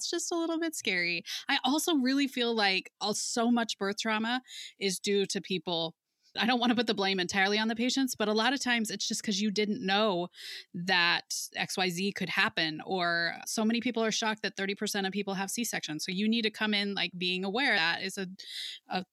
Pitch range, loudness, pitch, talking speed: 190-235 Hz, -30 LUFS, 205 Hz, 220 wpm